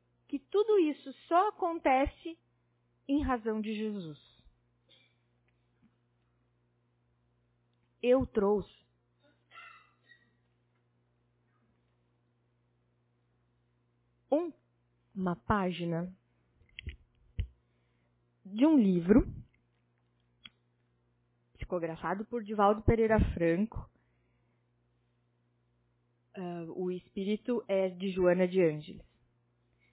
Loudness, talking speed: -31 LUFS, 60 wpm